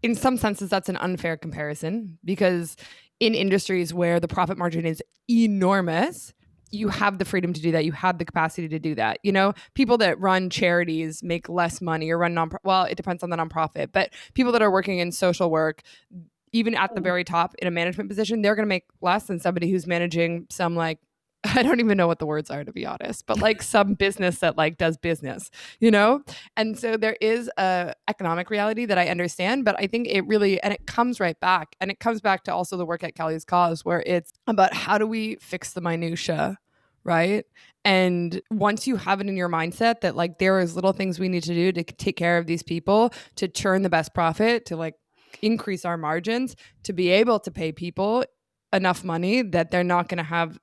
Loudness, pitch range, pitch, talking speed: -24 LUFS, 170-210 Hz, 185 Hz, 220 wpm